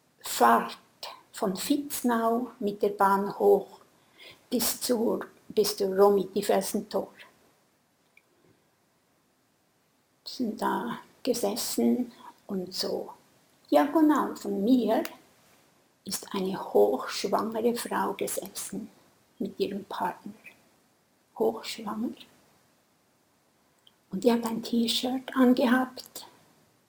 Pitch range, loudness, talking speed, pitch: 200-245 Hz, -28 LUFS, 75 wpm, 230 Hz